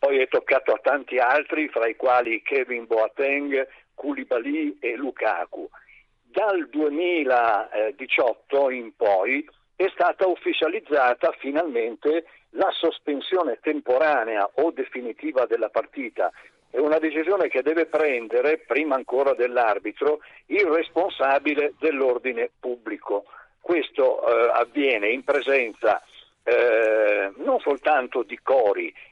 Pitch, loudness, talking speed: 170 Hz, -23 LUFS, 105 wpm